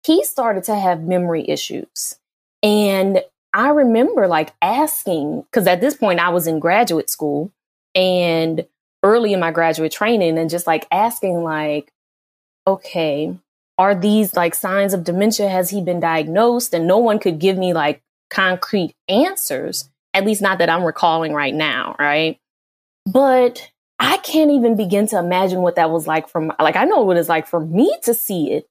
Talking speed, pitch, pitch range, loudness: 175 wpm, 180 Hz, 165-210 Hz, -17 LUFS